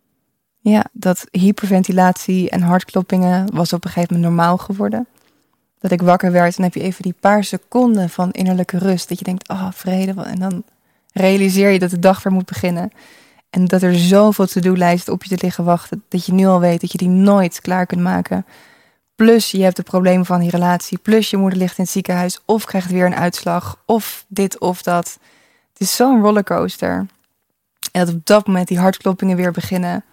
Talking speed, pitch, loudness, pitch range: 205 wpm, 185 Hz, -16 LUFS, 180-195 Hz